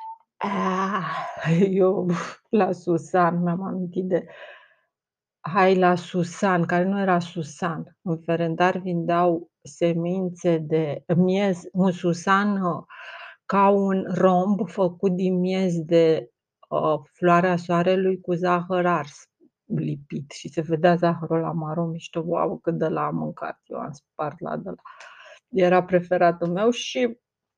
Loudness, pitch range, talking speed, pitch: -23 LUFS, 170-185 Hz, 130 wpm, 175 Hz